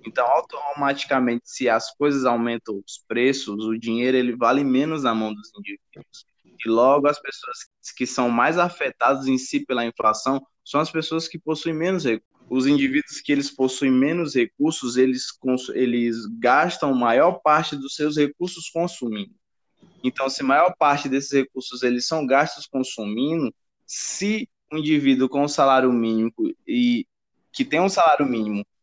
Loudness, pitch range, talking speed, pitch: -22 LUFS, 125-160 Hz, 160 wpm, 135 Hz